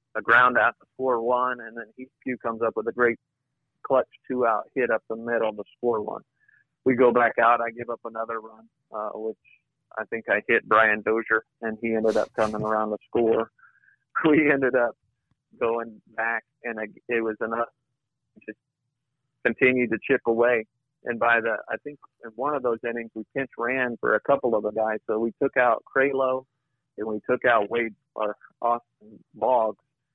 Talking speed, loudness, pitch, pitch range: 195 wpm, -25 LUFS, 120 Hz, 110-130 Hz